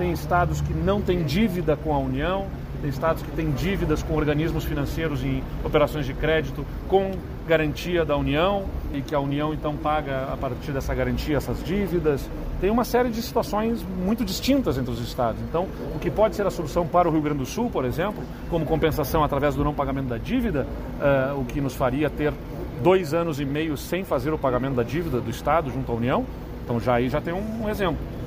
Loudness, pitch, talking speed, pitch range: -25 LUFS, 150 Hz, 210 wpm, 135-175 Hz